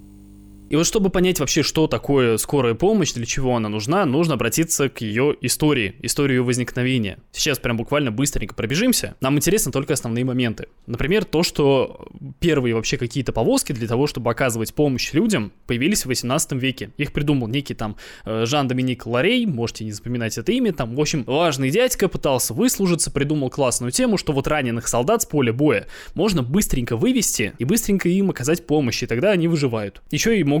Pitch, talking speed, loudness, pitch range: 140 Hz, 180 wpm, -20 LUFS, 120-160 Hz